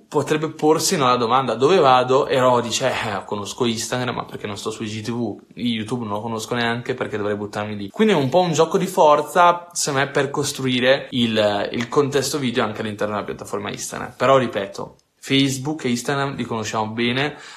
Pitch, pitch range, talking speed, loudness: 125 Hz, 115-145 Hz, 190 wpm, -20 LUFS